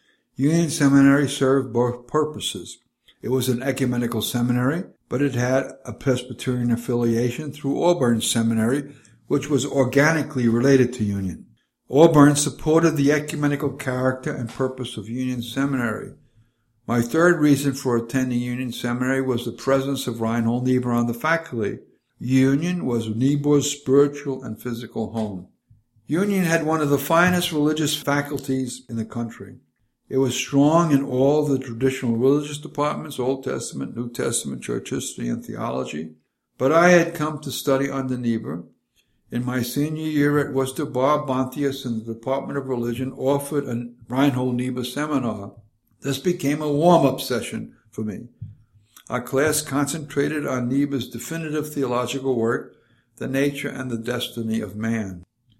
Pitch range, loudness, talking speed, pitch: 120-145 Hz, -22 LUFS, 145 wpm, 130 Hz